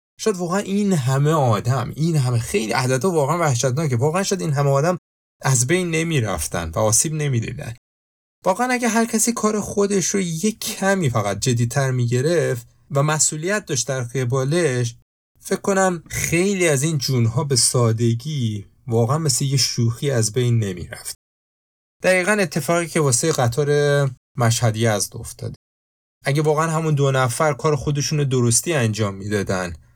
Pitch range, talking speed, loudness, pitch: 120-165 Hz, 155 wpm, -20 LUFS, 140 Hz